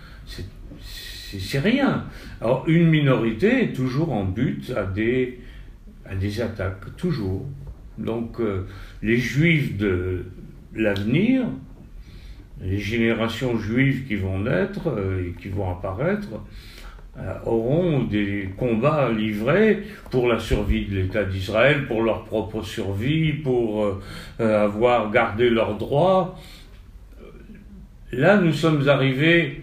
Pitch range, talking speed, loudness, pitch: 105-145 Hz, 120 wpm, -22 LUFS, 115 Hz